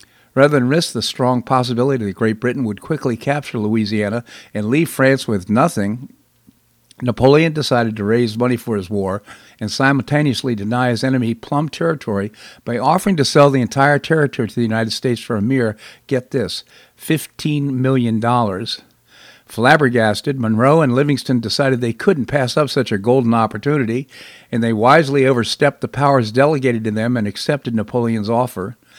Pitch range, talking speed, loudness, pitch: 115-140 Hz, 160 wpm, -17 LUFS, 125 Hz